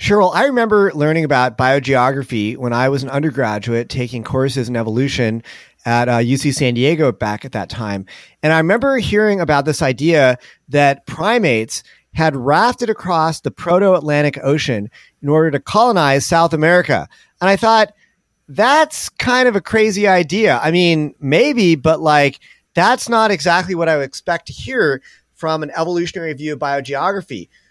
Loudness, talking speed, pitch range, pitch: -15 LUFS, 160 wpm, 130-180 Hz, 150 Hz